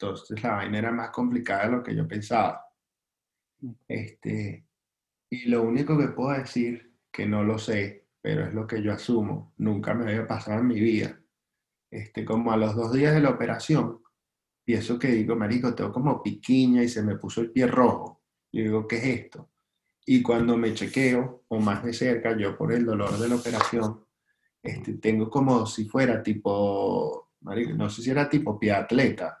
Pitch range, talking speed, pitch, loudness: 110-125 Hz, 190 wpm, 115 Hz, -26 LUFS